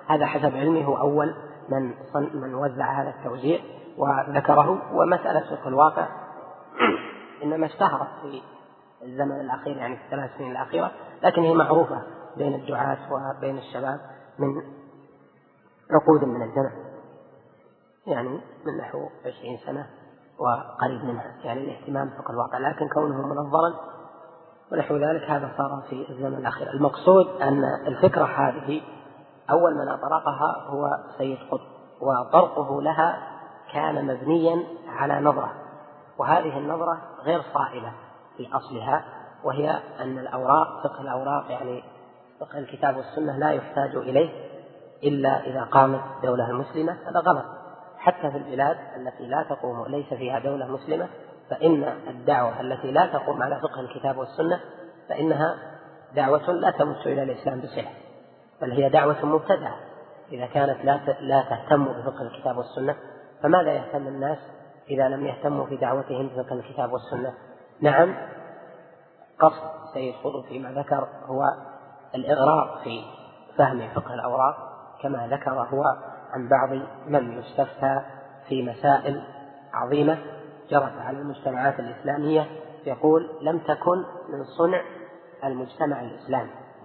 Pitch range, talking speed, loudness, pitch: 135-155 Hz, 125 wpm, -25 LUFS, 140 Hz